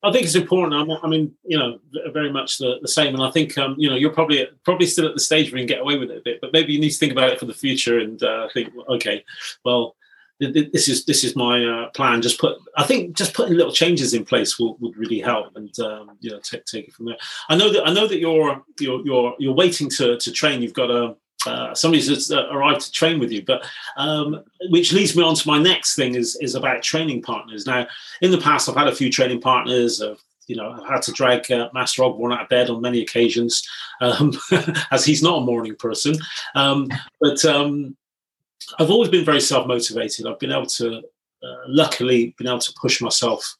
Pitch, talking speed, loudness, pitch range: 140 Hz, 240 wpm, -19 LUFS, 120-160 Hz